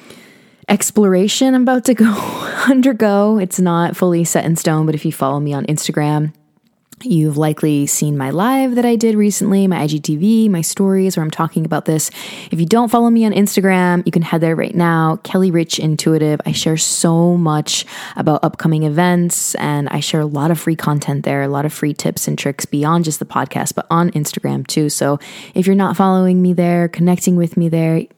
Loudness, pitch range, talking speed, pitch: -15 LUFS, 155-195 Hz, 200 wpm, 170 Hz